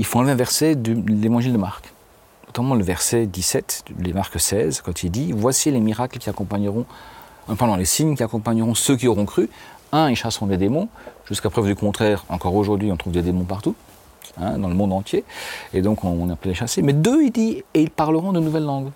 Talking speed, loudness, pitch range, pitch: 225 wpm, -21 LUFS, 95-125 Hz, 110 Hz